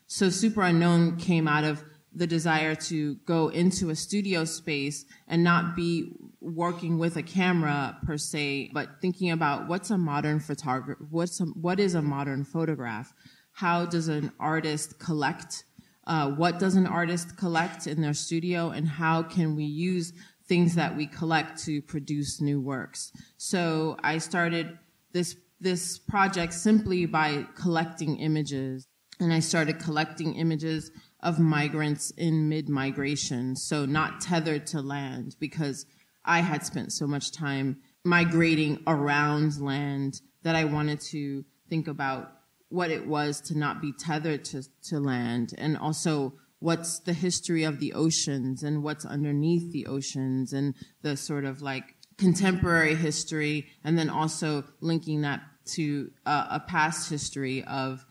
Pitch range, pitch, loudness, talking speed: 145-170 Hz, 155 Hz, -28 LUFS, 150 wpm